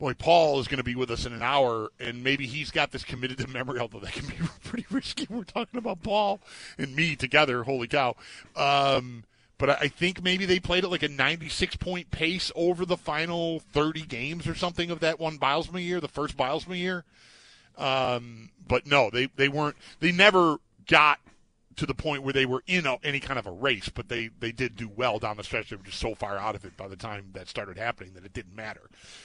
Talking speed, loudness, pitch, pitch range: 230 wpm, -27 LUFS, 140 Hz, 120-165 Hz